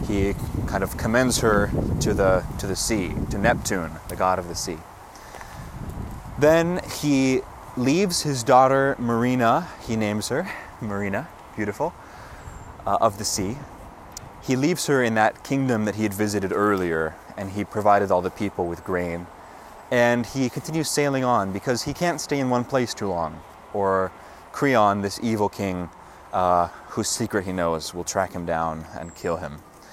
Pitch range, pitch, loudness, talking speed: 95-130 Hz, 105 Hz, -23 LUFS, 165 wpm